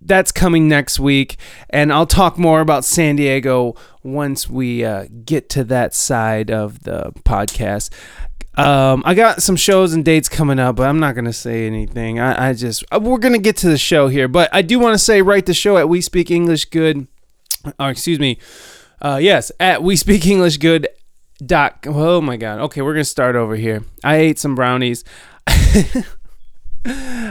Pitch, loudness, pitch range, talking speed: 145 Hz, -15 LUFS, 125-175 Hz, 190 wpm